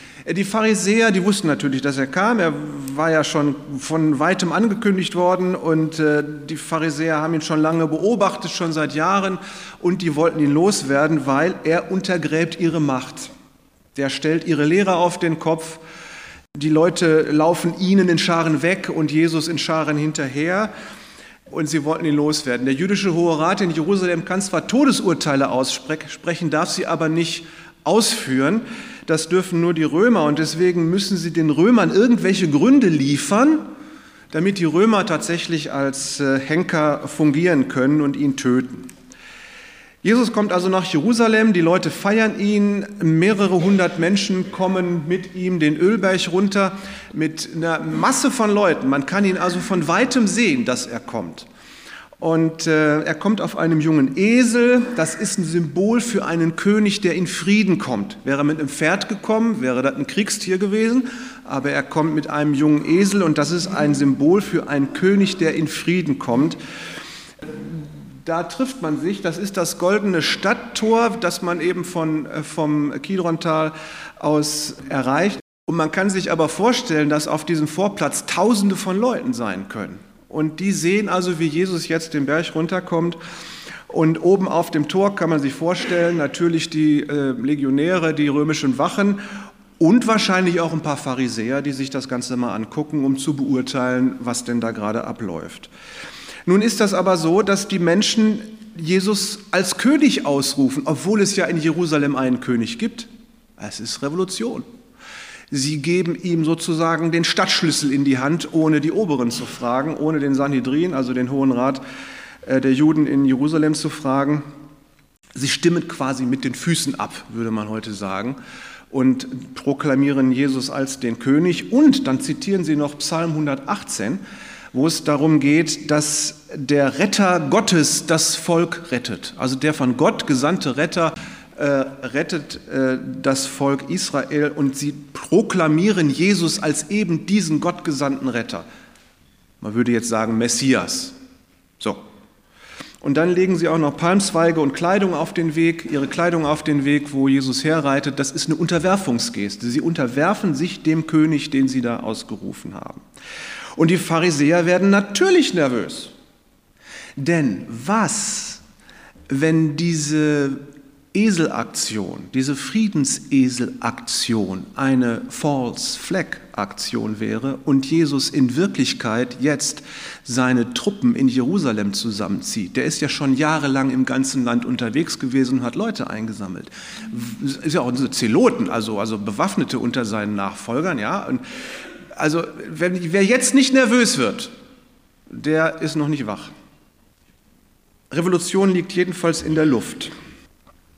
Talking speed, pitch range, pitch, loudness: 150 wpm, 145-190 Hz, 160 Hz, -19 LUFS